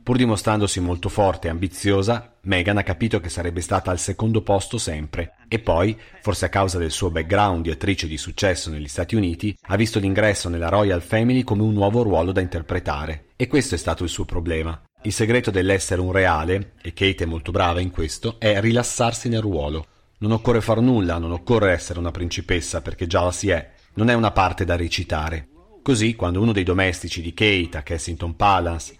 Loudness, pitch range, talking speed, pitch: -21 LUFS, 85-105 Hz, 200 wpm, 95 Hz